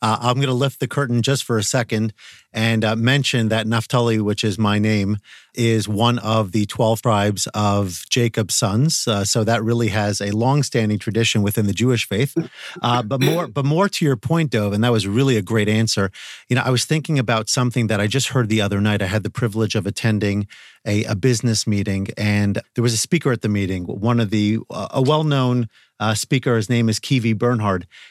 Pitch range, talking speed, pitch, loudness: 105-125 Hz, 220 wpm, 115 Hz, -19 LUFS